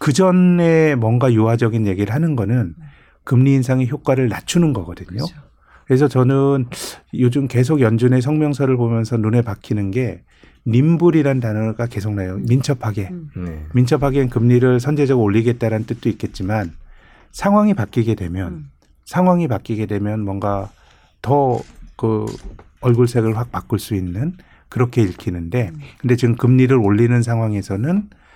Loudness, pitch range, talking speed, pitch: -17 LUFS, 105-135 Hz, 310 characters per minute, 120 Hz